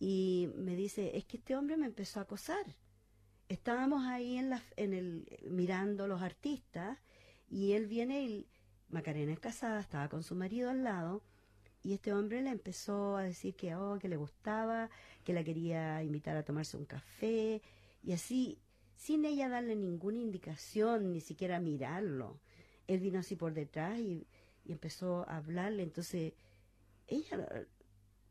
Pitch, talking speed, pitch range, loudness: 185 Hz, 160 wpm, 155-220 Hz, -40 LUFS